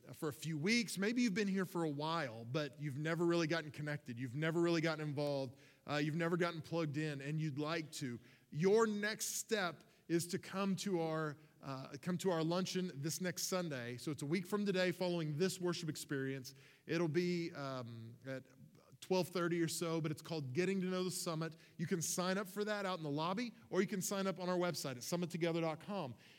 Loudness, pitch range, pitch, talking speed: -39 LUFS, 150-185 Hz, 165 Hz, 210 wpm